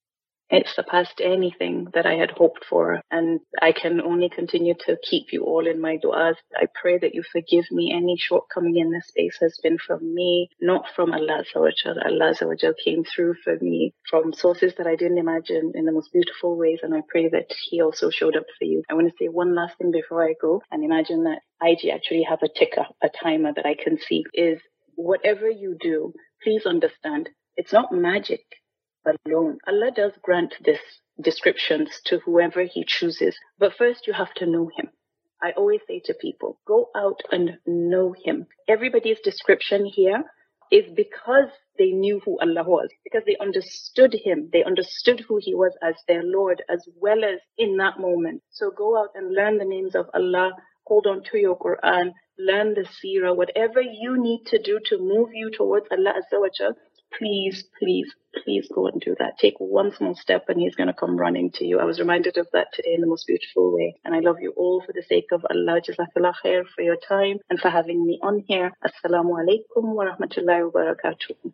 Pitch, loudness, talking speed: 190 Hz, -22 LUFS, 195 wpm